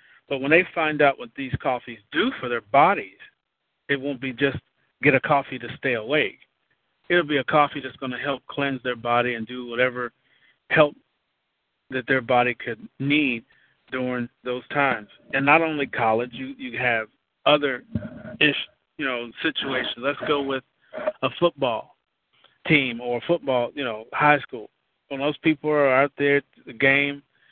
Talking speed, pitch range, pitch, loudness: 170 wpm, 125-145 Hz, 135 Hz, -23 LUFS